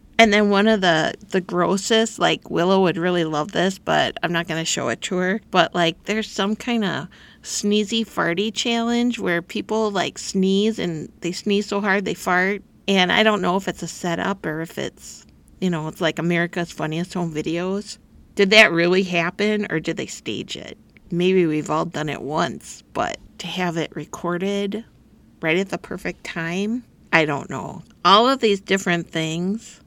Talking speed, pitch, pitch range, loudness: 190 wpm, 185 Hz, 170-210 Hz, -21 LUFS